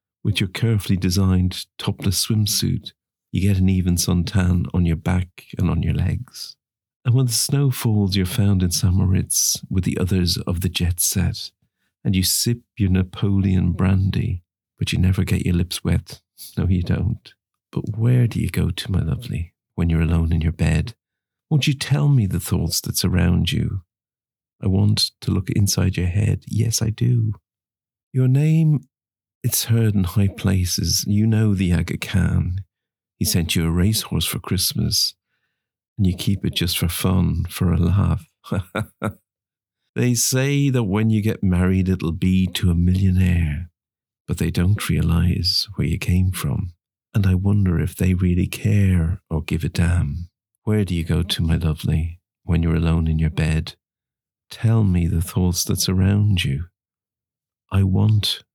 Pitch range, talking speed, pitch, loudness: 90-110 Hz, 170 wpm, 95 Hz, -20 LUFS